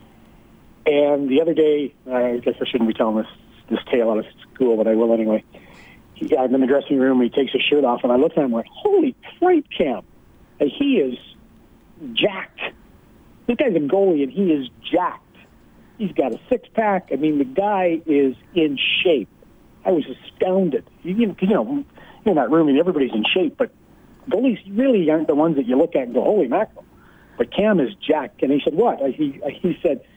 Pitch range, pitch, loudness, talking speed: 130-210 Hz, 155 Hz, -20 LUFS, 205 wpm